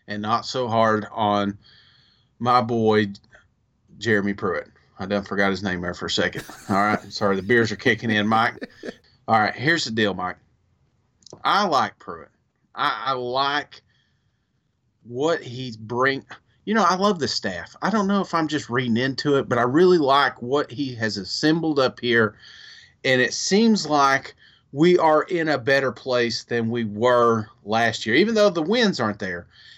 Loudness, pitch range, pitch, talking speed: -21 LUFS, 110-140 Hz, 120 Hz, 175 wpm